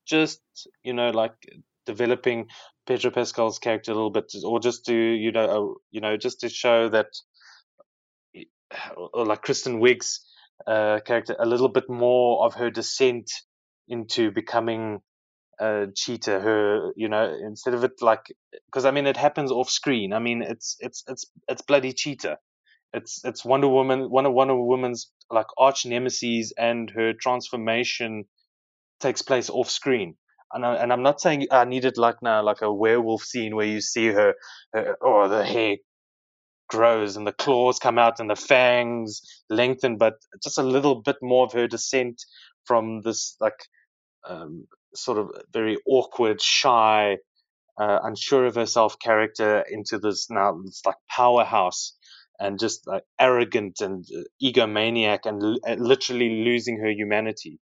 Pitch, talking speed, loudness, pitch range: 120 Hz, 160 wpm, -23 LUFS, 110-130 Hz